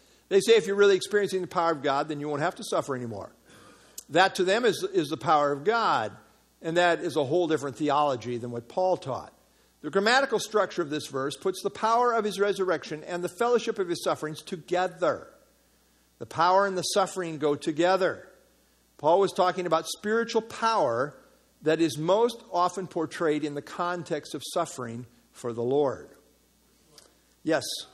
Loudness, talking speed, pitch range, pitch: -27 LUFS, 180 wpm, 150-195 Hz, 175 Hz